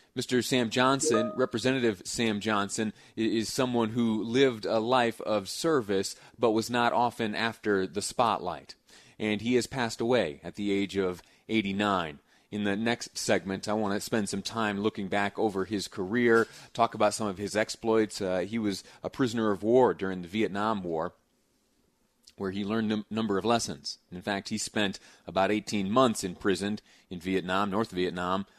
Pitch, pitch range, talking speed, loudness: 110 Hz, 100-115 Hz, 175 wpm, -29 LUFS